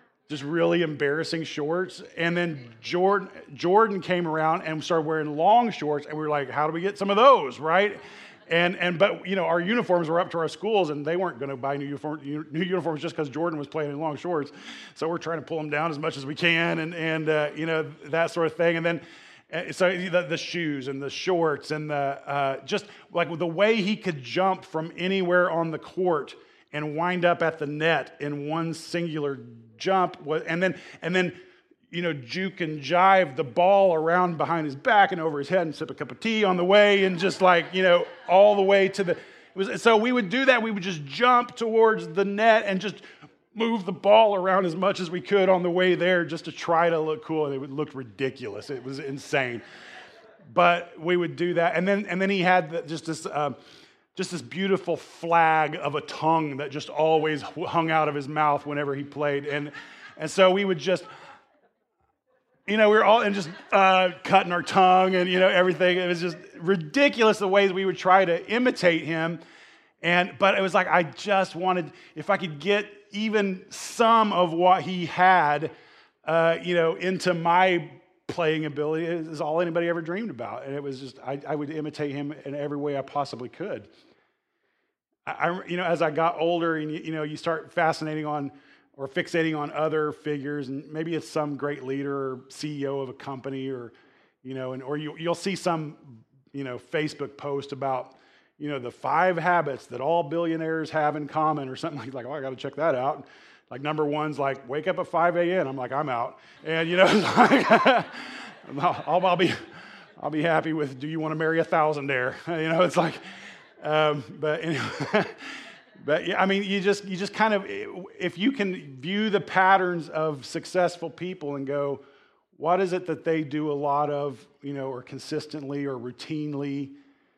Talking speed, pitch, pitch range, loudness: 210 wpm, 165 Hz, 150-185 Hz, -25 LUFS